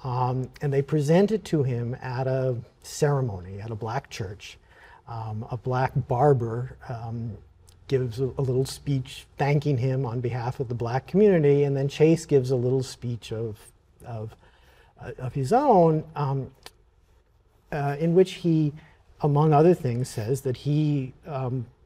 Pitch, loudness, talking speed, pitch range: 130 Hz, -25 LUFS, 155 wpm, 120-145 Hz